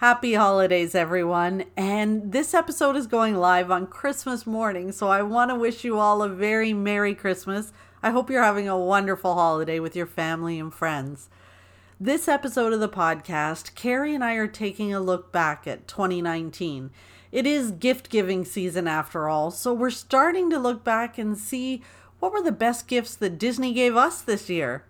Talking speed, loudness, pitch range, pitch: 185 wpm, -24 LUFS, 175-245 Hz, 205 Hz